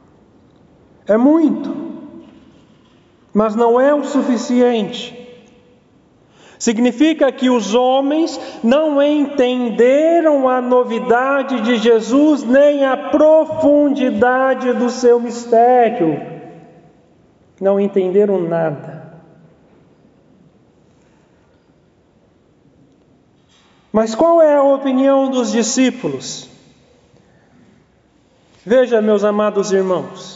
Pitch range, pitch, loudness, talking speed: 230-275 Hz, 250 Hz, -14 LUFS, 75 wpm